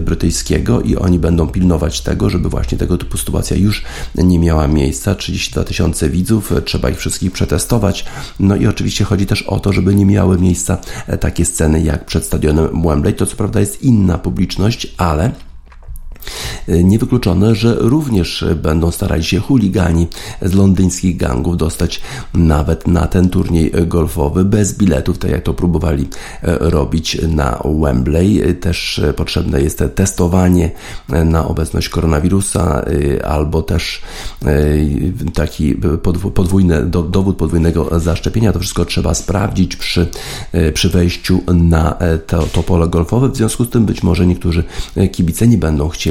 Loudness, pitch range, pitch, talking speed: -14 LUFS, 80-95 Hz, 85 Hz, 140 wpm